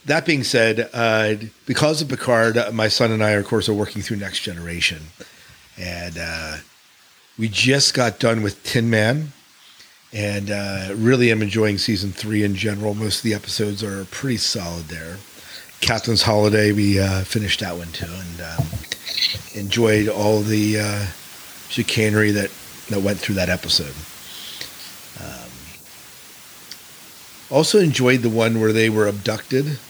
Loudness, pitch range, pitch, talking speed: -20 LUFS, 100-115 Hz, 105 Hz, 150 wpm